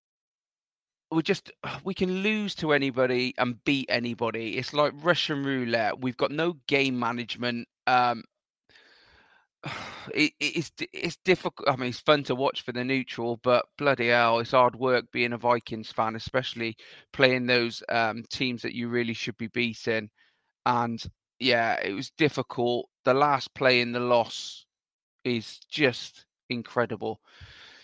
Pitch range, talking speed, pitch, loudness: 115-140 Hz, 145 wpm, 125 Hz, -27 LUFS